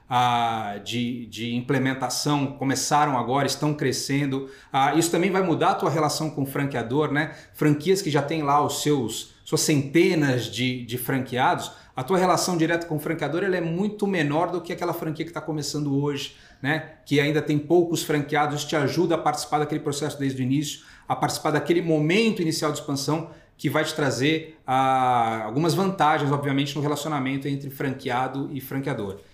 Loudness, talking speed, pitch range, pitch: -24 LUFS, 180 wpm, 135-155 Hz, 150 Hz